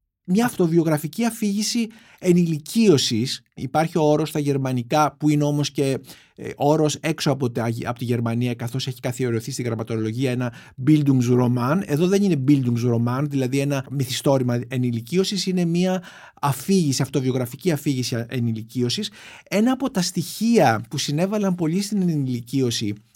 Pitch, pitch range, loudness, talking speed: 140 Hz, 125-175 Hz, -22 LUFS, 130 wpm